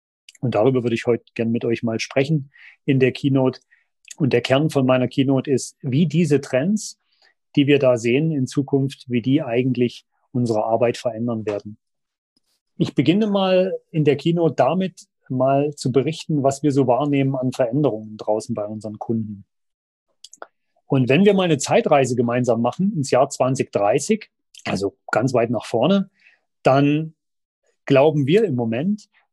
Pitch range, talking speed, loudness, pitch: 120-155 Hz, 160 wpm, -20 LUFS, 135 Hz